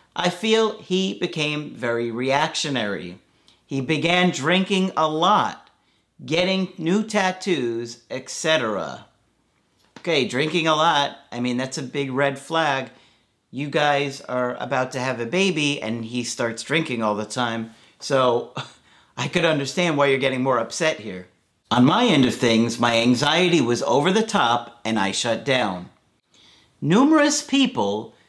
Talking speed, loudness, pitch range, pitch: 145 wpm, -21 LUFS, 120-175 Hz, 140 Hz